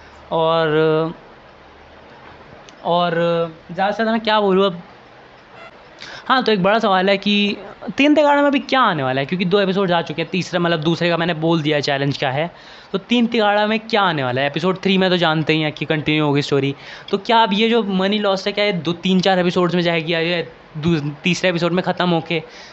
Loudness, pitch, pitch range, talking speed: -18 LUFS, 175 Hz, 160-200 Hz, 215 wpm